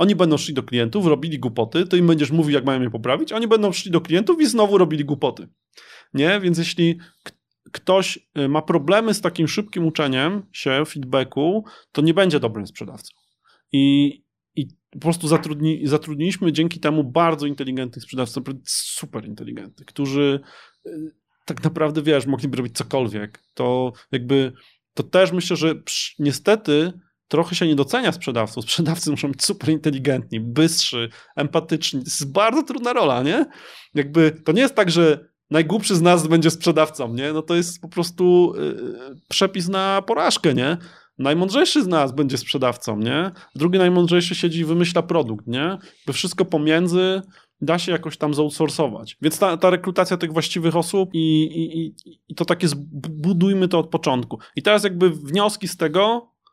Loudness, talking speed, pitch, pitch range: -20 LUFS, 165 wpm, 160 Hz, 145-180 Hz